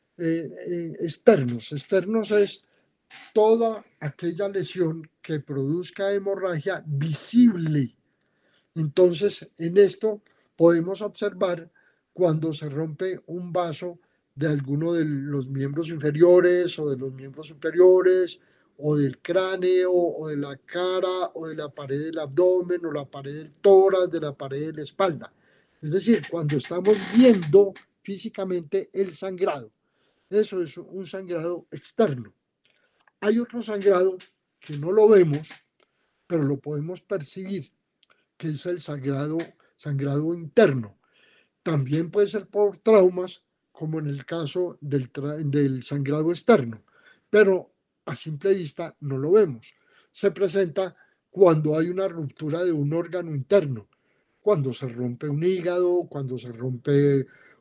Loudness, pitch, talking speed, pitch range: -24 LUFS, 170 Hz, 130 wpm, 150-190 Hz